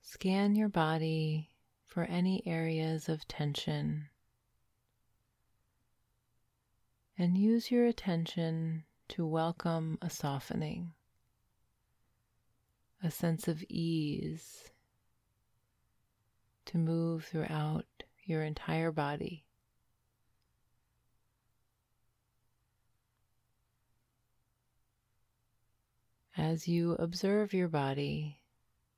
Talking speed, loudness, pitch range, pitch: 65 wpm, -35 LUFS, 115-165 Hz, 120 Hz